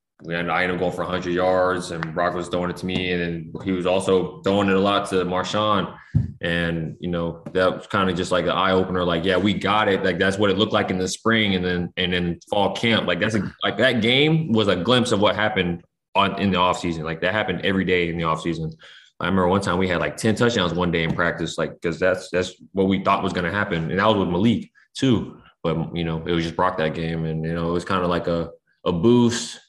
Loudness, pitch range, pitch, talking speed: -22 LUFS, 85-95 Hz, 90 Hz, 270 wpm